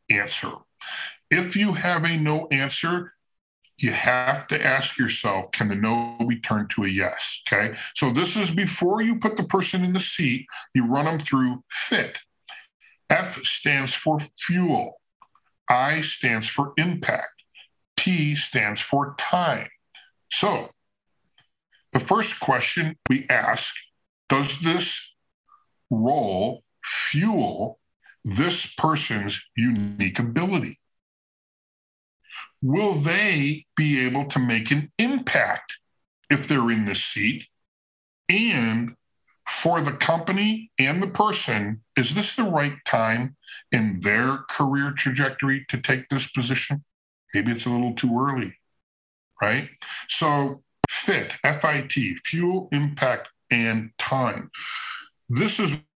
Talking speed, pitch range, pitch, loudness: 120 wpm, 125-170 Hz, 140 Hz, -23 LUFS